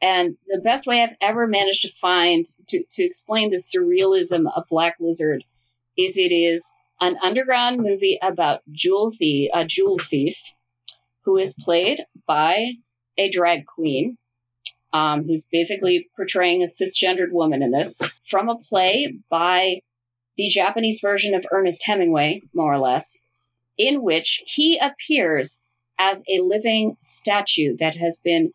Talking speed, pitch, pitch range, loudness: 145 wpm, 185 Hz, 165-215 Hz, -20 LUFS